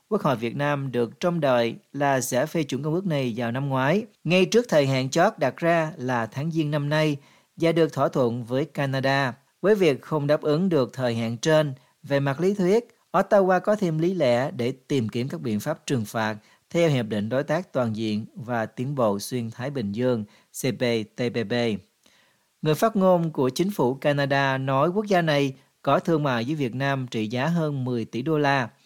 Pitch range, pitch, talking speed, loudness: 125-165 Hz, 140 Hz, 210 wpm, -24 LUFS